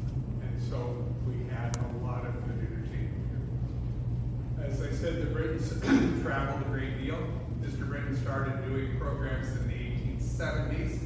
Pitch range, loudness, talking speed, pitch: 120-130 Hz, -33 LUFS, 140 wpm, 120 Hz